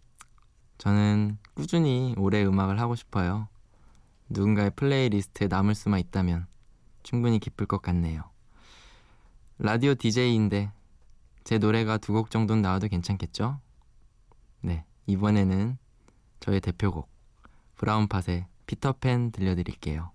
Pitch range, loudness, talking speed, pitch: 95-115 Hz, -27 LUFS, 265 characters per minute, 105 Hz